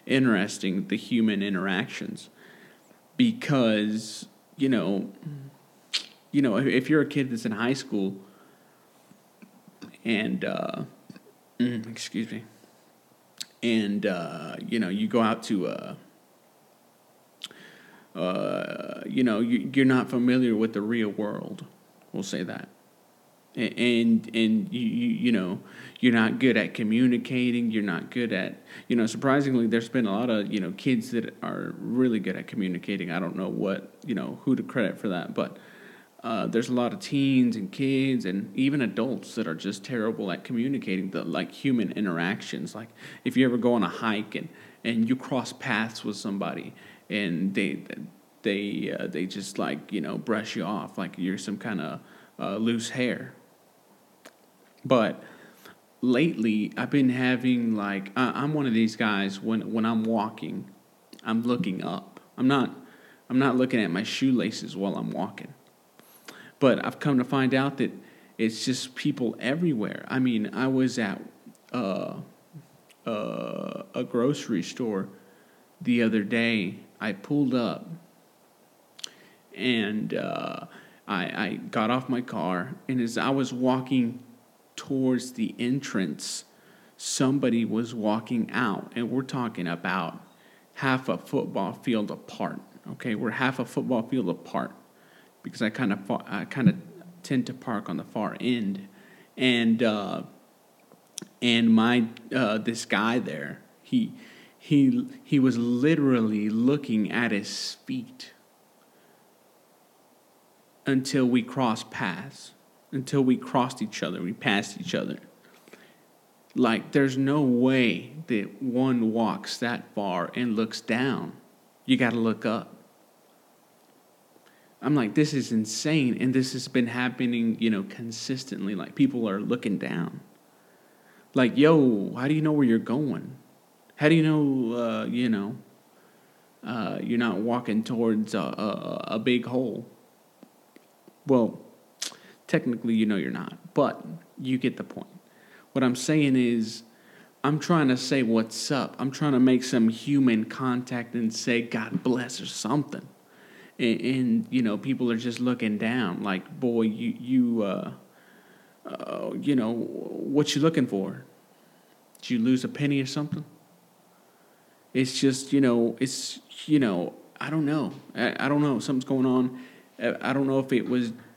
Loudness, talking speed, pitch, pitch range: -27 LUFS, 150 wpm, 125 Hz, 115-135 Hz